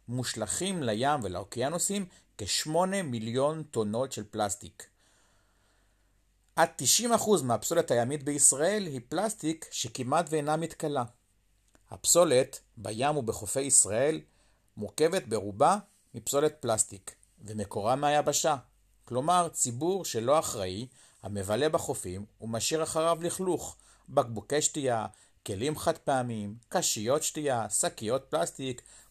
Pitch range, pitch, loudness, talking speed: 105-155 Hz, 125 Hz, -29 LUFS, 95 wpm